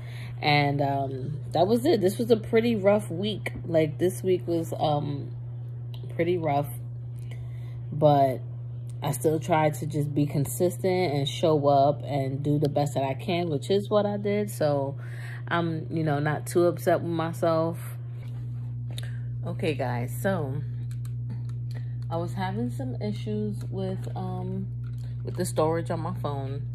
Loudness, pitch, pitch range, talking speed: -27 LUFS, 120 Hz, 120-145 Hz, 150 wpm